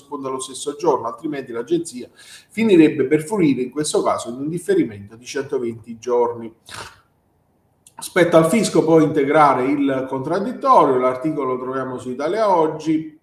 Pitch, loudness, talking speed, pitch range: 145 Hz, -19 LUFS, 135 wpm, 130-160 Hz